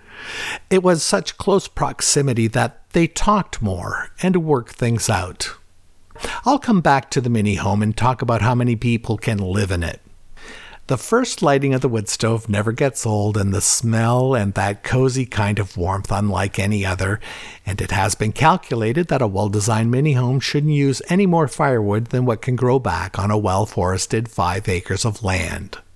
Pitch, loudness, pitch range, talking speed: 115 Hz, -19 LUFS, 100-135 Hz, 185 wpm